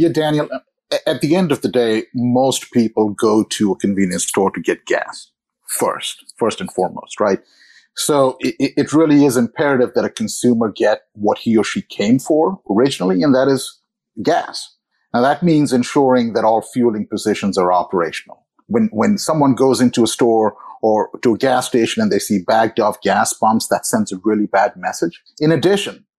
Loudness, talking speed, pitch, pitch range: -16 LUFS, 185 wpm, 125 Hz, 110-150 Hz